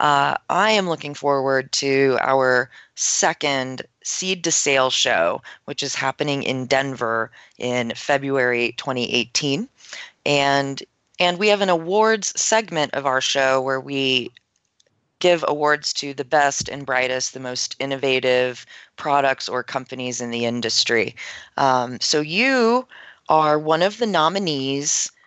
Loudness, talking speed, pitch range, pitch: -20 LUFS, 135 wpm, 130-155 Hz, 140 Hz